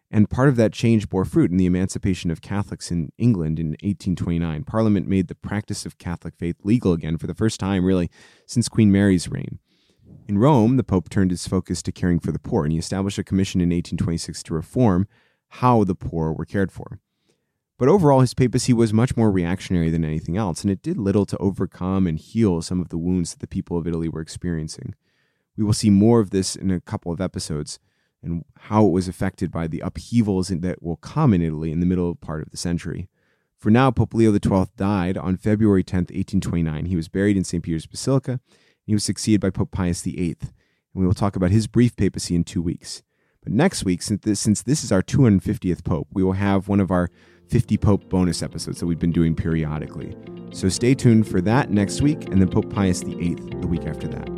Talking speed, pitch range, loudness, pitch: 225 wpm, 85-105 Hz, -22 LUFS, 95 Hz